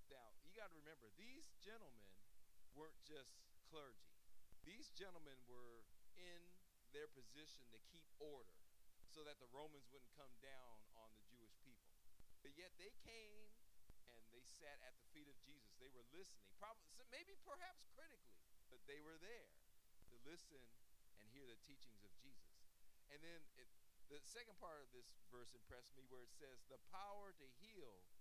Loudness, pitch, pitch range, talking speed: -64 LUFS, 135 Hz, 115-165 Hz, 170 wpm